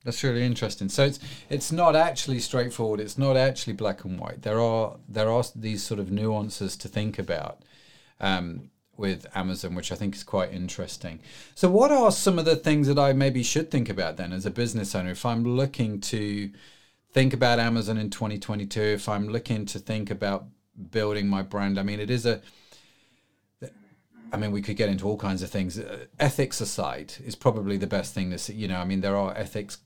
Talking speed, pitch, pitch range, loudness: 205 wpm, 105 Hz, 100-125 Hz, -26 LUFS